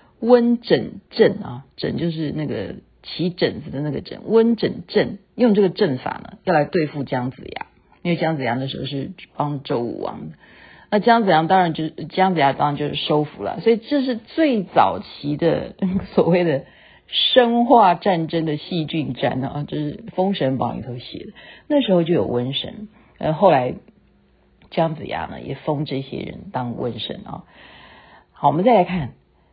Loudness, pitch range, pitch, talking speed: -20 LUFS, 140-200 Hz, 165 Hz, 245 characters per minute